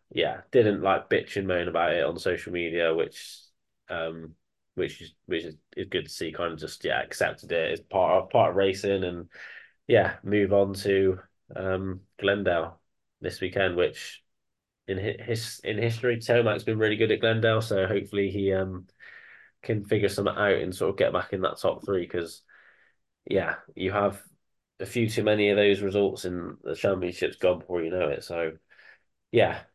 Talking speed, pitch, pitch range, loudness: 180 wpm, 100 Hz, 90-105 Hz, -27 LUFS